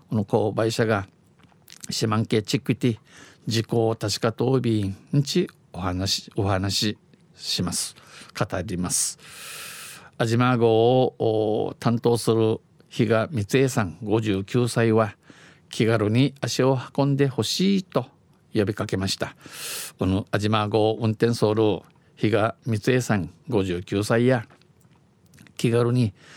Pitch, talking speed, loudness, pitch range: 115 Hz, 215 characters per minute, -24 LUFS, 105-125 Hz